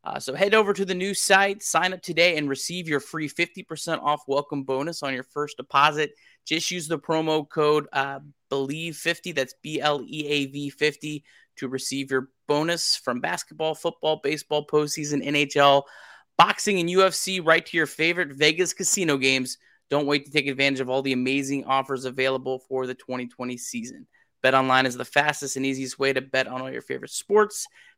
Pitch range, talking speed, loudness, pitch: 135-170 Hz, 175 wpm, -24 LUFS, 150 Hz